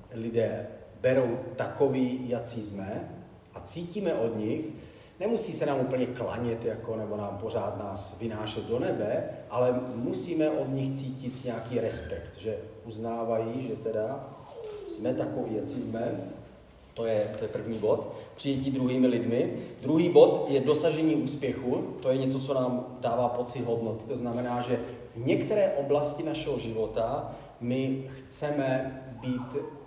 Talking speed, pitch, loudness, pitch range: 140 wpm, 125 Hz, -30 LUFS, 115-145 Hz